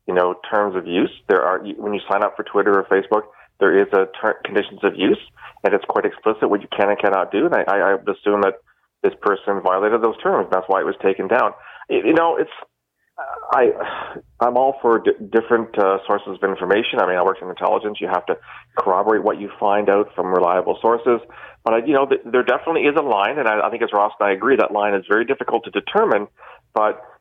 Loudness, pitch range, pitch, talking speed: -19 LUFS, 105-155 Hz, 115 Hz, 225 wpm